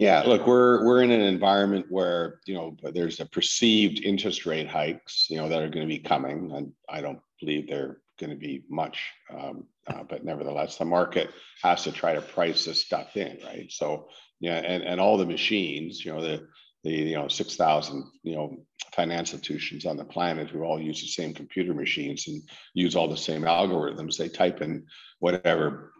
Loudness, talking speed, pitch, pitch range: -26 LUFS, 200 wpm, 85 Hz, 80-100 Hz